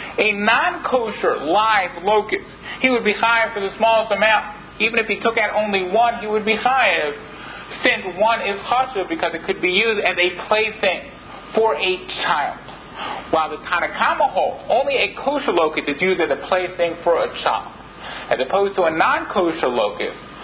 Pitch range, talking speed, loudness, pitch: 185-225 Hz, 180 wpm, -19 LUFS, 210 Hz